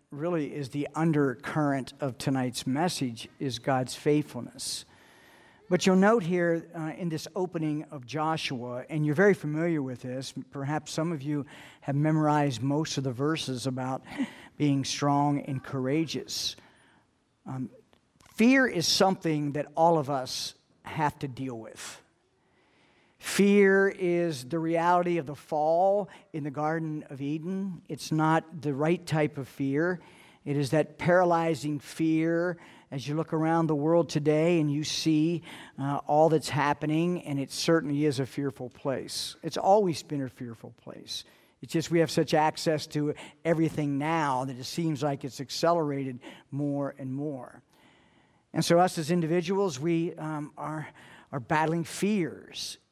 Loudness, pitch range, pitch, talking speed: -28 LUFS, 140-165 Hz, 155 Hz, 150 wpm